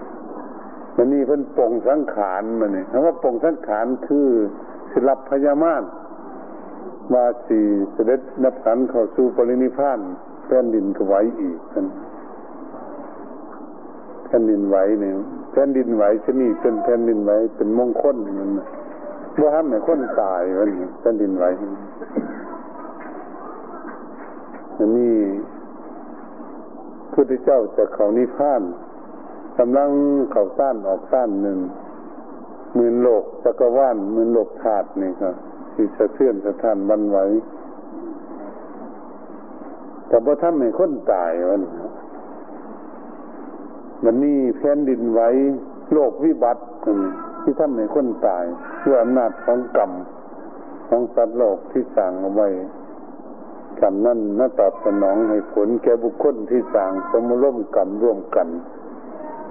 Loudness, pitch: -19 LUFS, 145 Hz